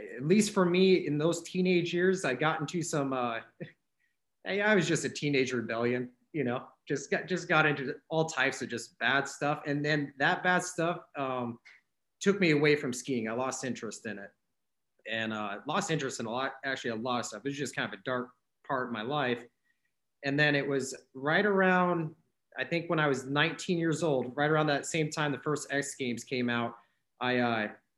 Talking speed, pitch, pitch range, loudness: 210 wpm, 140 Hz, 125-165 Hz, -30 LUFS